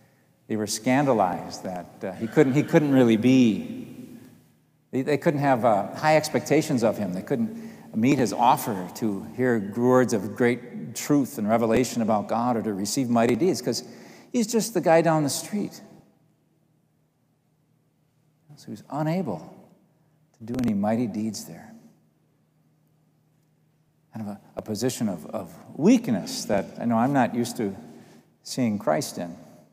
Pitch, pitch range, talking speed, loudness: 145 Hz, 120-155 Hz, 155 wpm, -24 LUFS